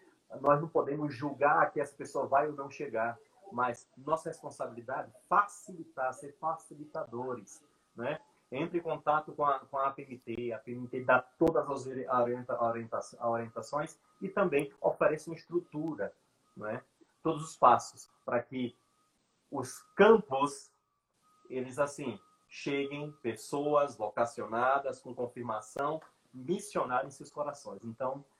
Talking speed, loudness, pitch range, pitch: 125 wpm, -33 LUFS, 125-160 Hz, 140 Hz